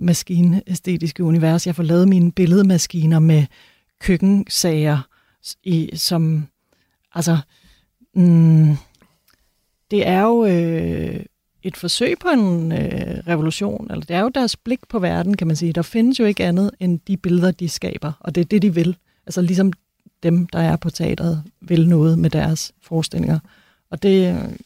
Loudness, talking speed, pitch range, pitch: -18 LUFS, 155 wpm, 165-190 Hz, 175 Hz